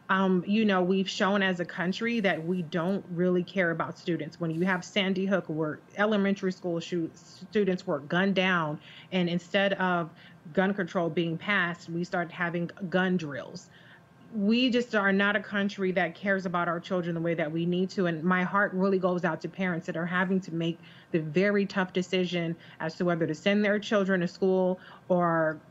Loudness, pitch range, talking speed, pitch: -28 LUFS, 170-195 Hz, 195 wpm, 180 Hz